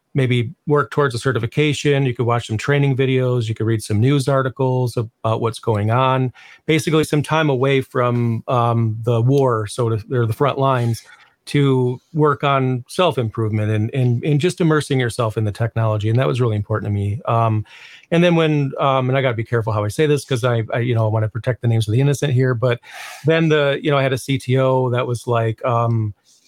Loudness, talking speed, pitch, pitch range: -18 LUFS, 220 wpm, 125 Hz, 115-140 Hz